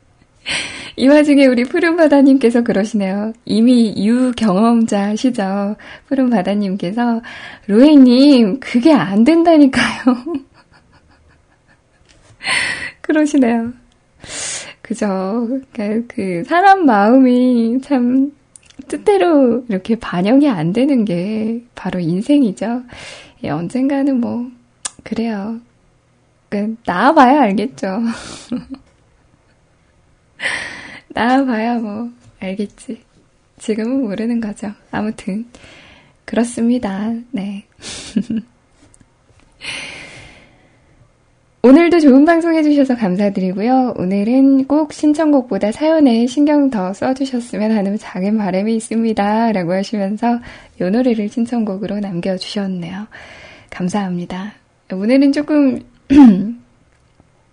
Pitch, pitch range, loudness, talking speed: 235 Hz, 205-270 Hz, -14 LUFS, 210 characters per minute